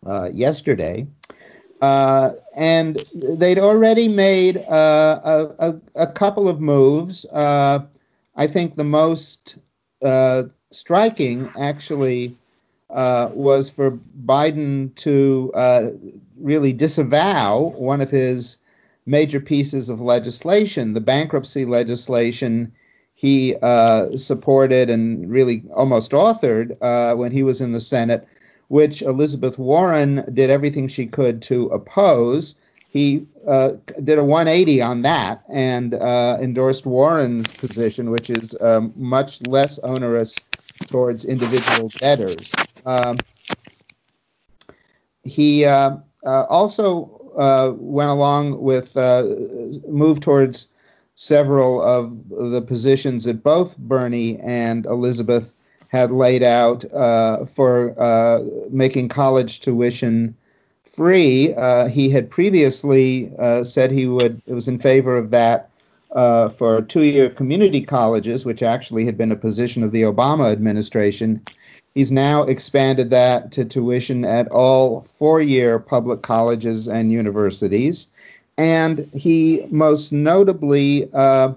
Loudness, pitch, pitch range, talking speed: -17 LUFS, 130 Hz, 120-145 Hz, 120 wpm